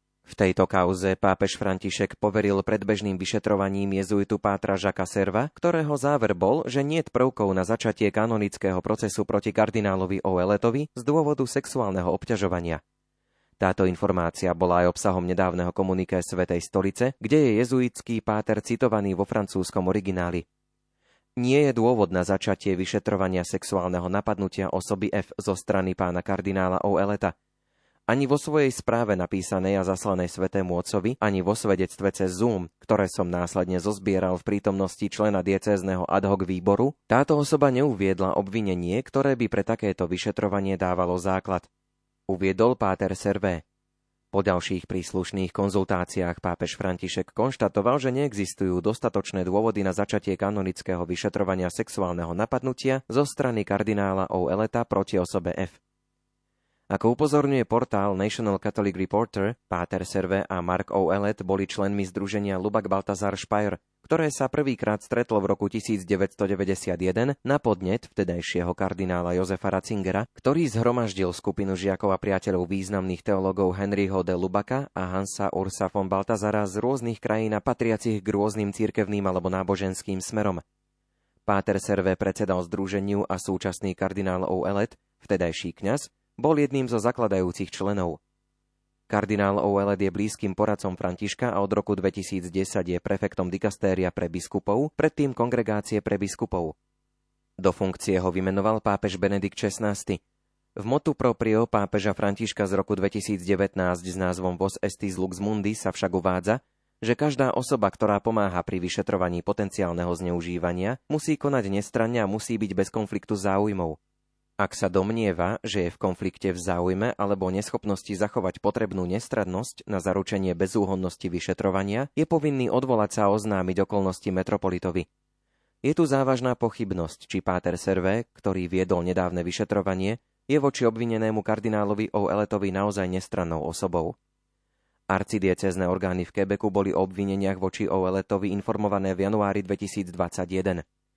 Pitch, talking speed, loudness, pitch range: 100 Hz, 135 wpm, -26 LUFS, 95-110 Hz